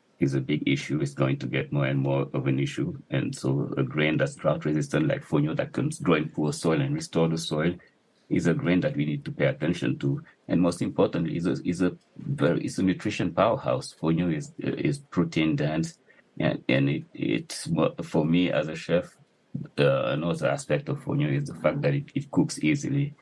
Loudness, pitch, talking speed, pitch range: -27 LUFS, 80 Hz, 210 wpm, 70-95 Hz